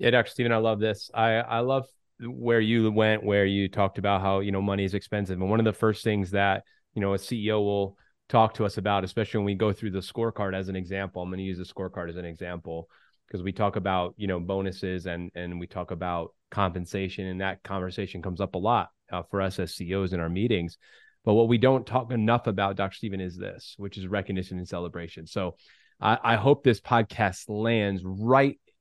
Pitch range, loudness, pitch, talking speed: 95-110 Hz, -27 LUFS, 100 Hz, 225 wpm